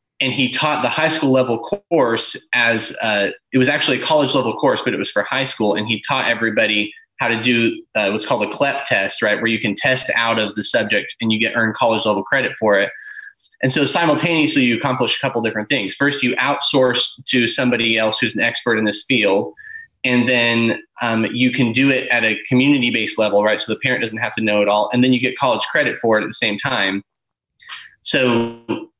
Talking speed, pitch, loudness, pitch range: 230 wpm, 120 Hz, -17 LUFS, 110-135 Hz